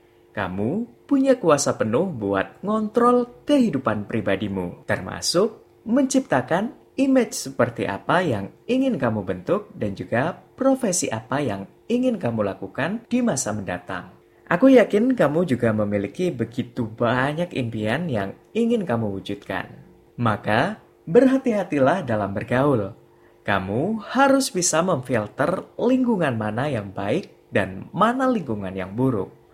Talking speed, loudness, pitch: 115 wpm, -22 LUFS, 135 Hz